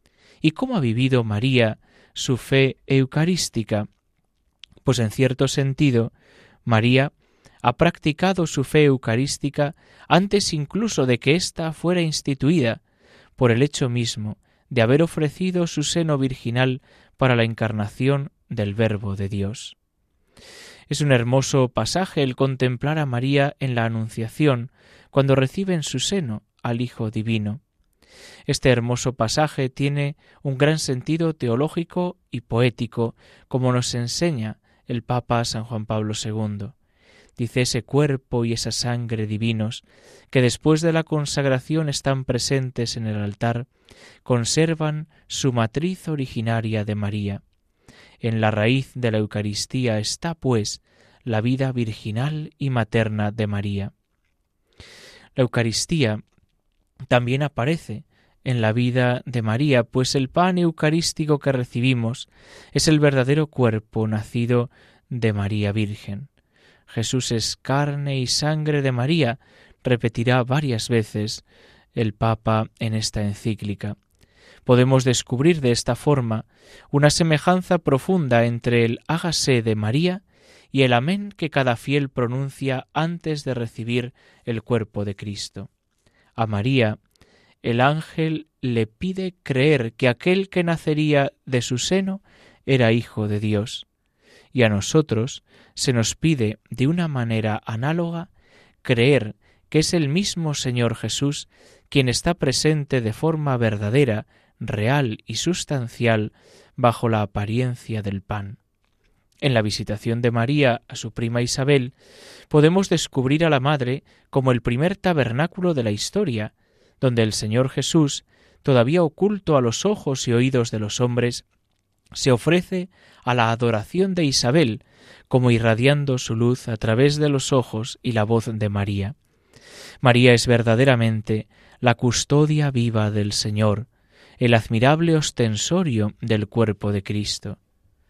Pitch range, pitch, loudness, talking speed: 110-145 Hz, 125 Hz, -22 LUFS, 130 wpm